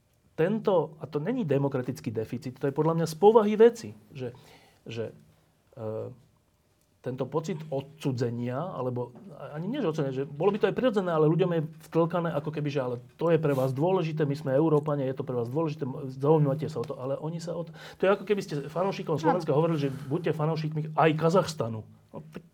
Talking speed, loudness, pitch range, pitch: 195 wpm, -28 LUFS, 135-165 Hz, 150 Hz